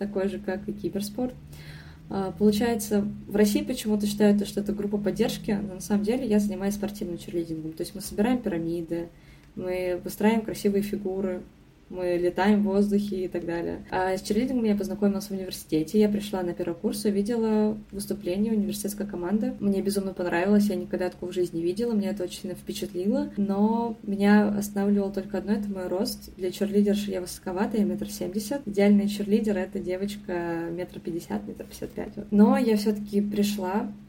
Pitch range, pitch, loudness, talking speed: 185-210 Hz, 200 Hz, -27 LUFS, 170 wpm